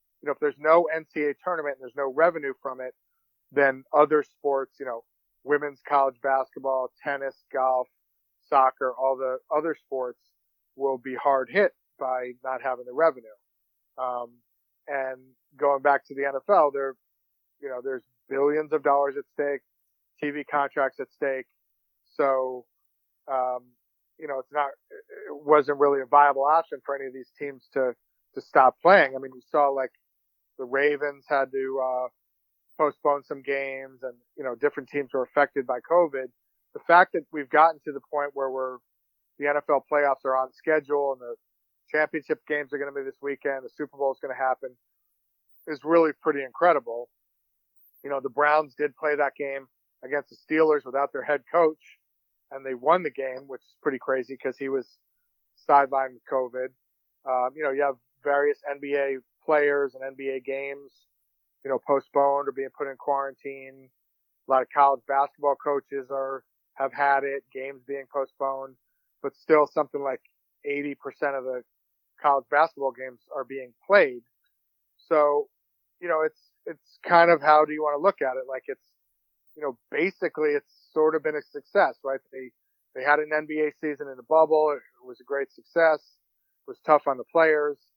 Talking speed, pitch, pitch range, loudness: 175 wpm, 140 Hz, 130-150 Hz, -25 LUFS